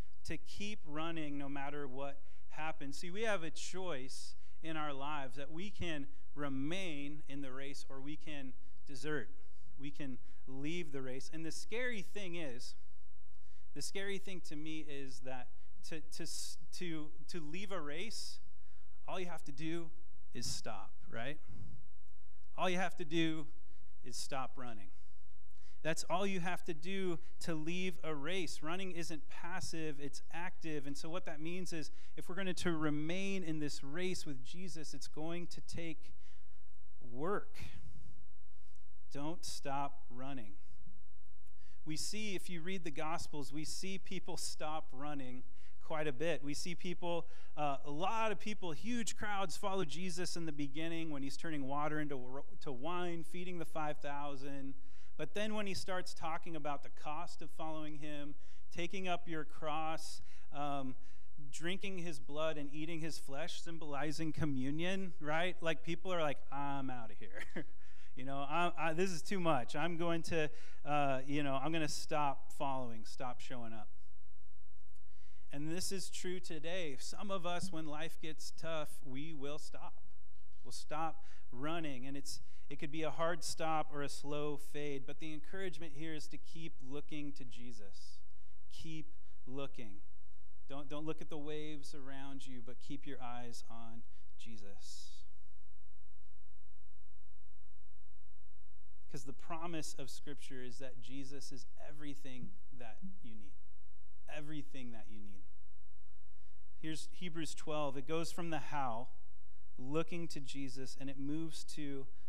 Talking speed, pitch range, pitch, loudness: 155 wpm, 105-160 Hz, 145 Hz, -44 LUFS